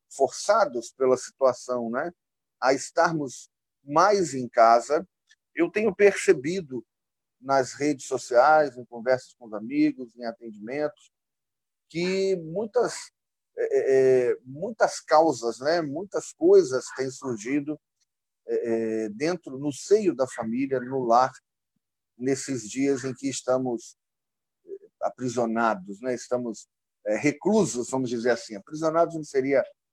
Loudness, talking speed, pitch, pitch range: -25 LUFS, 110 wpm, 135 Hz, 125-170 Hz